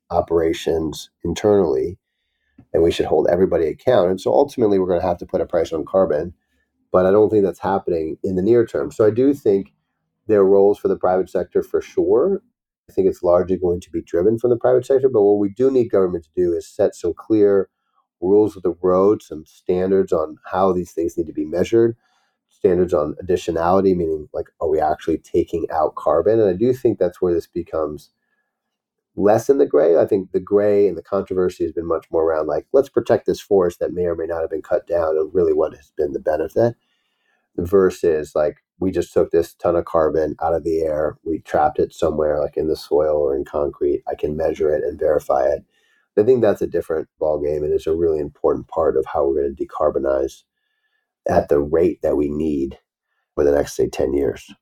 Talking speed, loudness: 220 wpm, -19 LUFS